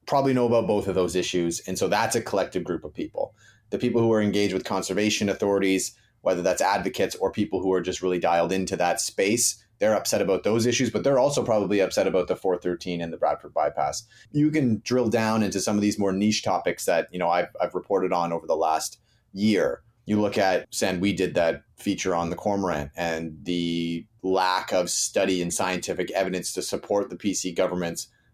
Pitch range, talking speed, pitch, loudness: 90-110 Hz, 205 wpm, 95 Hz, -25 LUFS